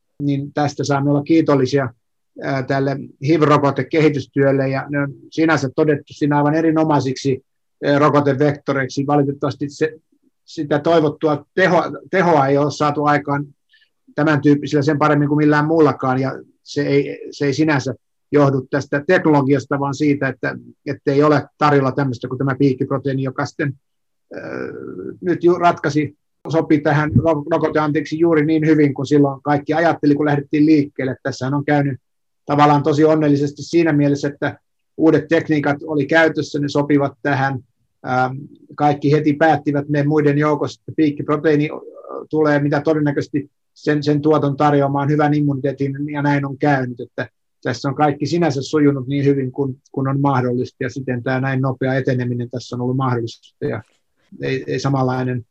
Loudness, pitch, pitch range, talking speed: -18 LUFS, 145 Hz, 135-150 Hz, 145 wpm